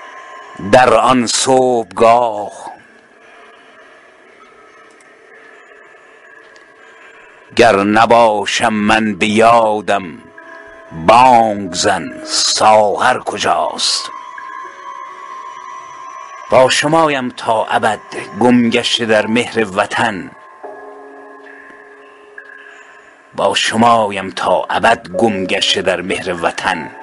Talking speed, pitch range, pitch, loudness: 65 wpm, 70-115 Hz, 110 Hz, -12 LUFS